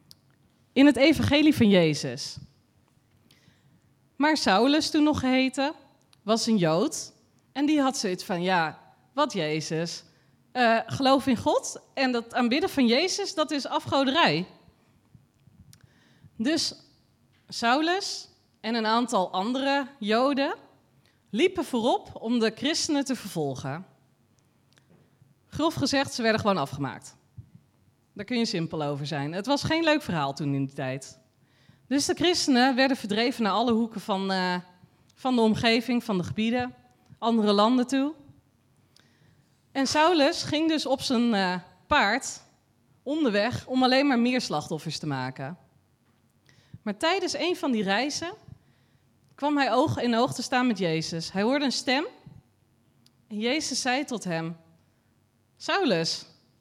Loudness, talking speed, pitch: -25 LUFS, 135 wpm, 220 Hz